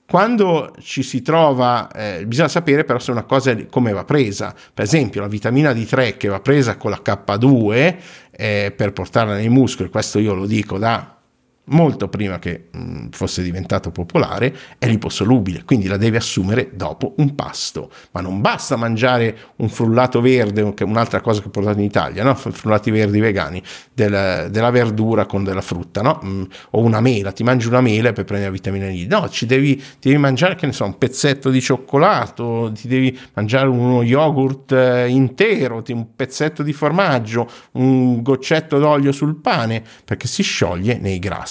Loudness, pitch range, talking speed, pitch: -17 LUFS, 100-135 Hz, 180 wpm, 120 Hz